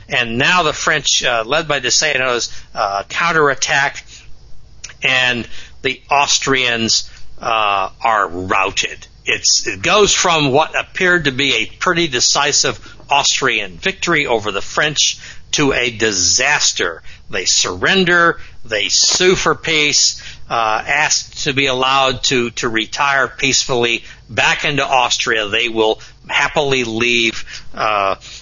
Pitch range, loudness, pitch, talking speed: 115-145 Hz, -14 LUFS, 130 Hz, 120 wpm